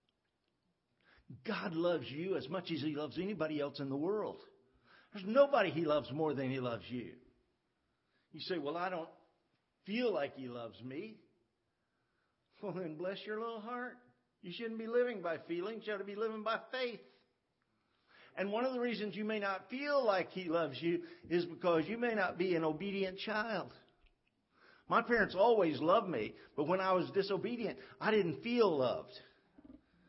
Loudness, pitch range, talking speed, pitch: -37 LUFS, 160-225 Hz, 175 wpm, 190 Hz